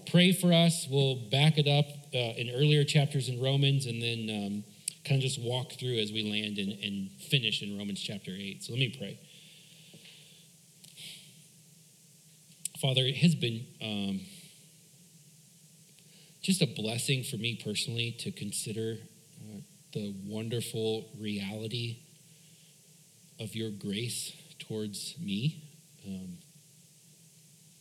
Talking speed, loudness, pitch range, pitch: 125 wpm, -31 LUFS, 115-160 Hz, 150 Hz